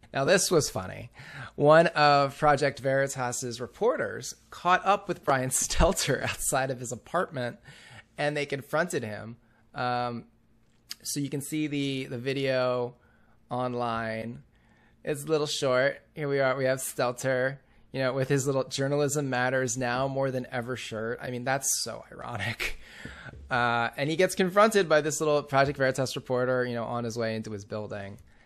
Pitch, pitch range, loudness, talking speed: 130 Hz, 120-145 Hz, -28 LUFS, 160 wpm